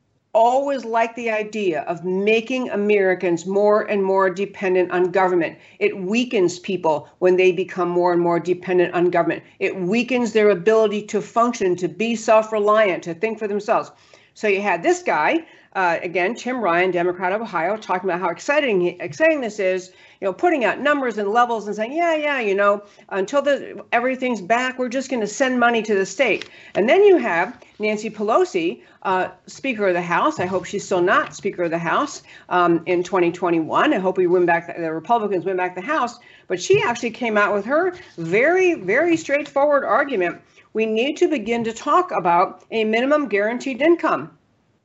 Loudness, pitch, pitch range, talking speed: -20 LUFS, 210 Hz, 185-250 Hz, 185 wpm